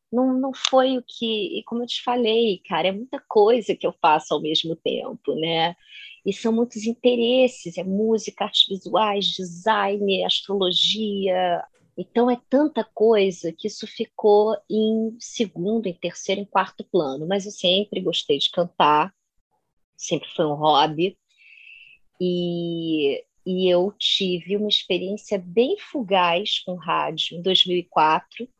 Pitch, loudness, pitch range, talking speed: 200 Hz, -22 LUFS, 180-225 Hz, 140 wpm